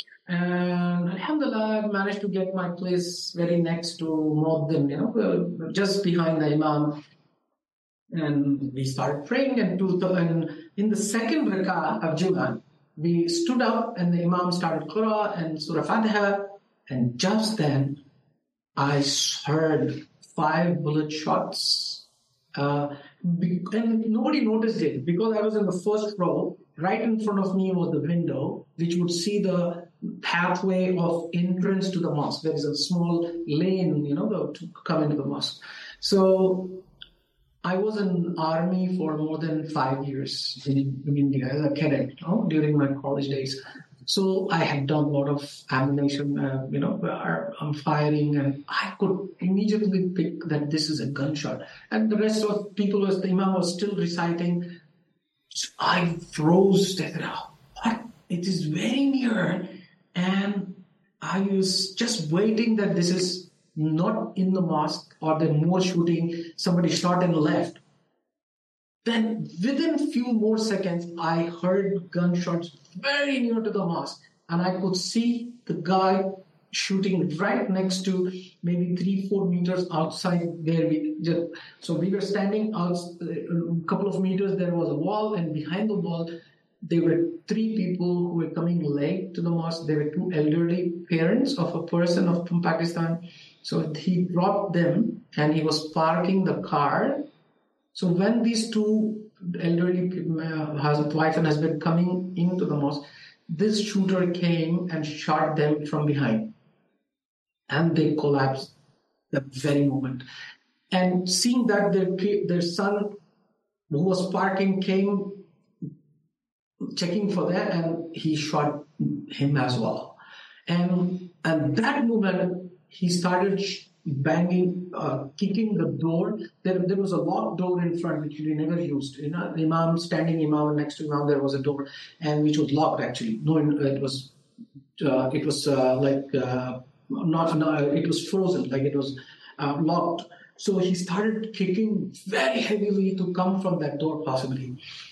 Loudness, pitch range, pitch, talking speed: -25 LUFS, 155-195 Hz, 175 Hz, 155 wpm